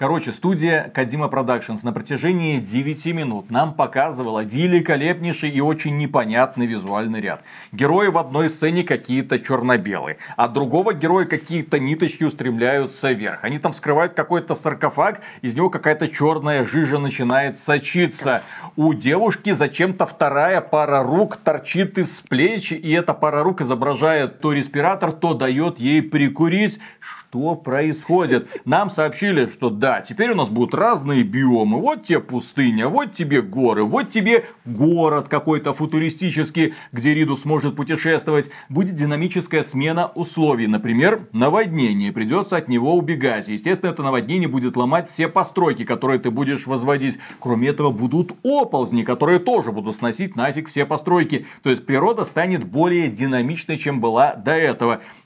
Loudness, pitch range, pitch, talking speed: -19 LUFS, 135-175 Hz, 155 Hz, 140 wpm